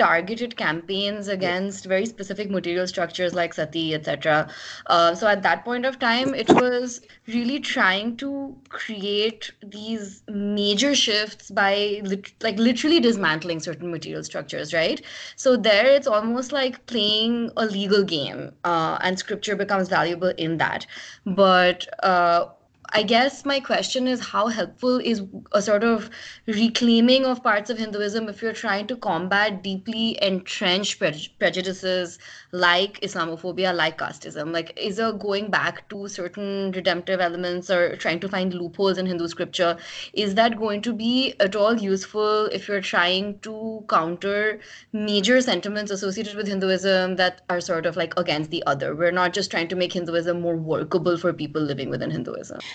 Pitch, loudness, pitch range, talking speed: 200 Hz, -23 LUFS, 180-225 Hz, 155 wpm